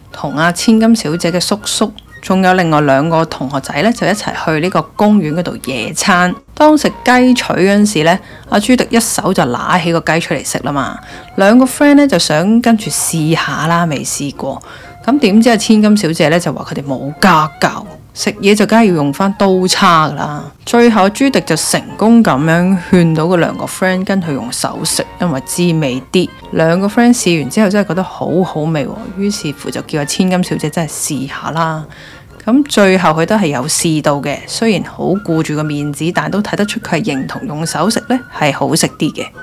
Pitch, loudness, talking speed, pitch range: 175 Hz, -12 LUFS, 310 characters per minute, 155-210 Hz